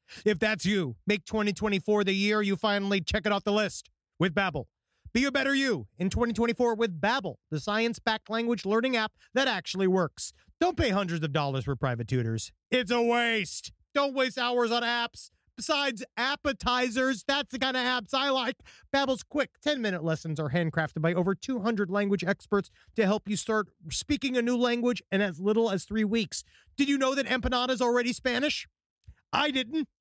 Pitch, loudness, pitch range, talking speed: 225 Hz, -28 LUFS, 195-255 Hz, 185 wpm